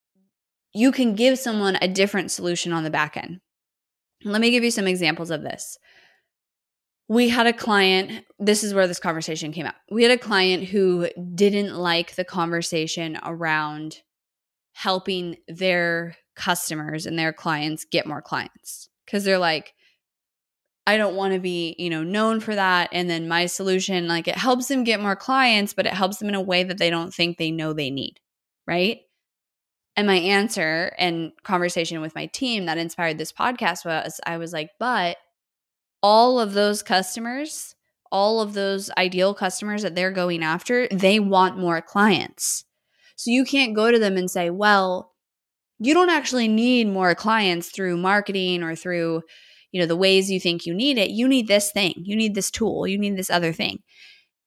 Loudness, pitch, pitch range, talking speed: -22 LUFS, 185 Hz, 170-210 Hz, 180 wpm